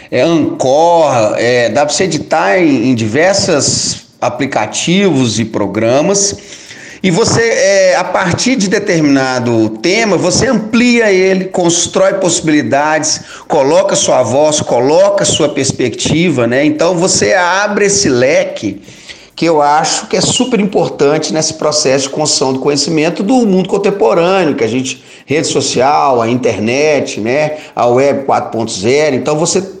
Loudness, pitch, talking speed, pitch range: -11 LUFS, 160 Hz, 135 wpm, 140-200 Hz